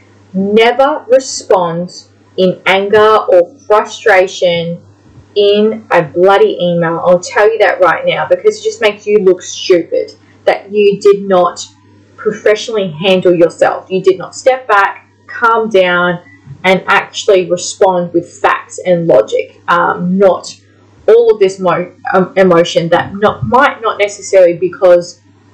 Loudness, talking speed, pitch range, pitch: -11 LUFS, 135 wpm, 175-210 Hz, 190 Hz